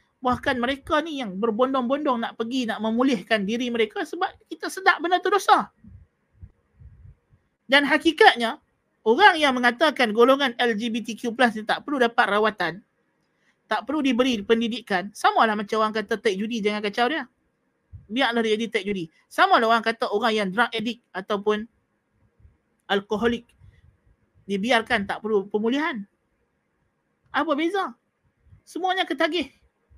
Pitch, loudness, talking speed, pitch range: 235 Hz, -23 LUFS, 130 wpm, 220-290 Hz